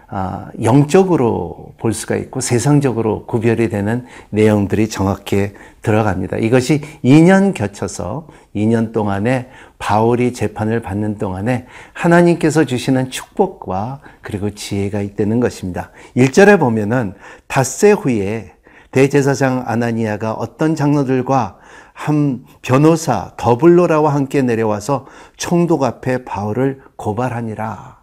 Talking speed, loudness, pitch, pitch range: 275 characters per minute, -16 LUFS, 120 Hz, 105-140 Hz